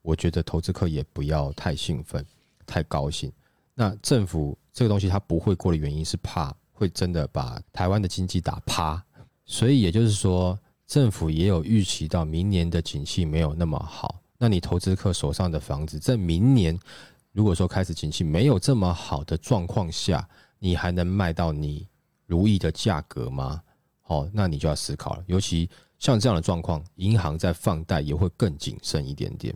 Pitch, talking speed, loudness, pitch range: 90 Hz, 275 characters per minute, -25 LUFS, 80-100 Hz